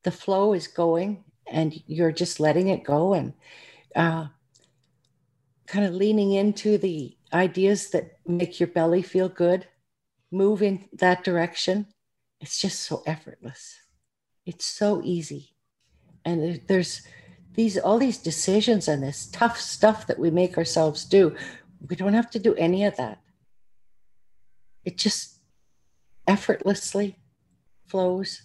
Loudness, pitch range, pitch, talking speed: -24 LUFS, 165-200 Hz, 180 Hz, 130 wpm